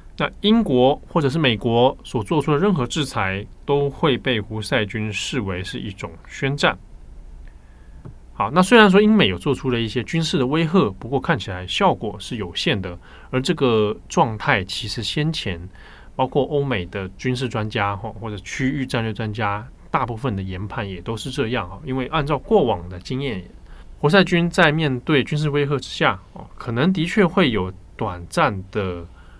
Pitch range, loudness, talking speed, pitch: 100-150 Hz, -21 LUFS, 260 characters per minute, 125 Hz